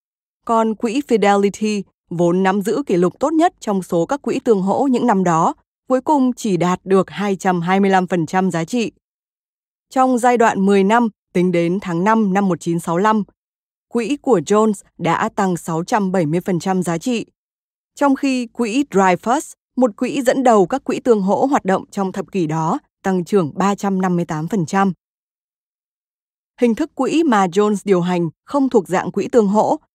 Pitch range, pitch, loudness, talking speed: 185-240 Hz, 200 Hz, -17 LUFS, 160 wpm